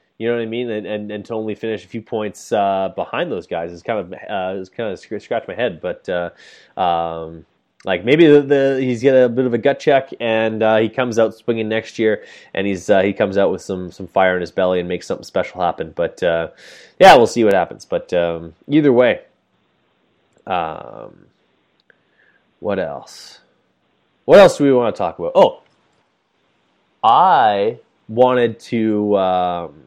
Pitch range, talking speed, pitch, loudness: 90-120 Hz, 195 wpm, 110 Hz, -17 LUFS